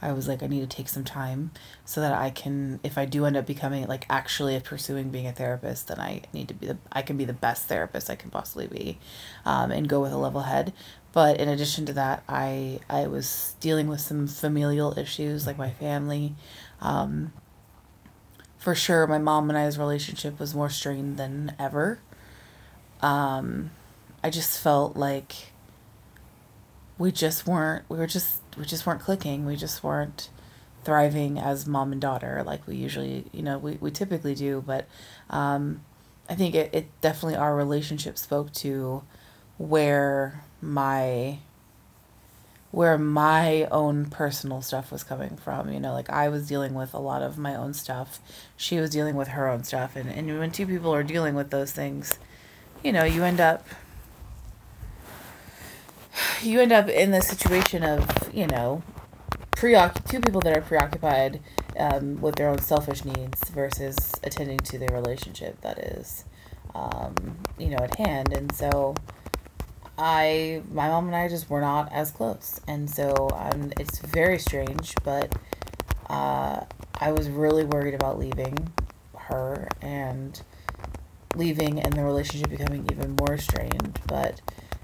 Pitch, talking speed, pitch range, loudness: 140 Hz, 165 wpm, 130-150 Hz, -27 LUFS